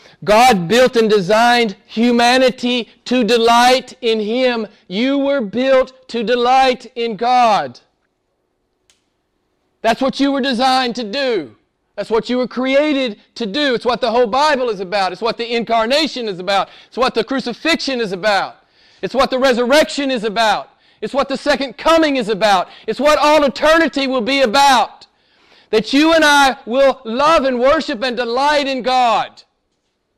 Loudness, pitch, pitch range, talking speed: -15 LUFS, 250 Hz, 230-275 Hz, 160 wpm